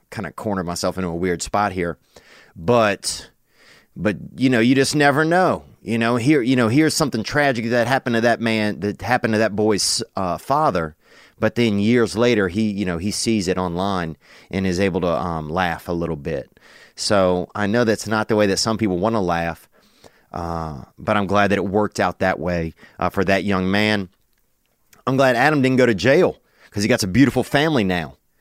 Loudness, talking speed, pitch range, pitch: -19 LUFS, 210 wpm, 90-120 Hz, 105 Hz